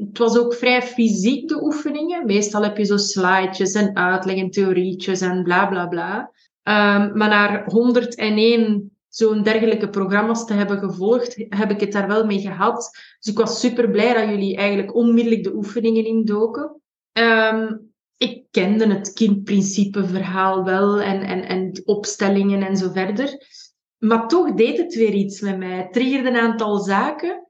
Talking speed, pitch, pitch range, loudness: 165 wpm, 210 Hz, 195-230 Hz, -19 LUFS